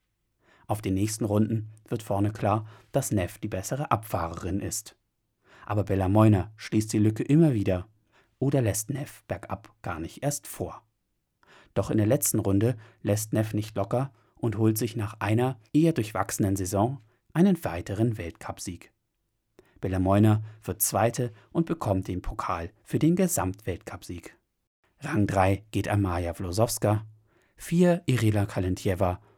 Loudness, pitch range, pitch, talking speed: -27 LUFS, 100-115 Hz, 105 Hz, 135 wpm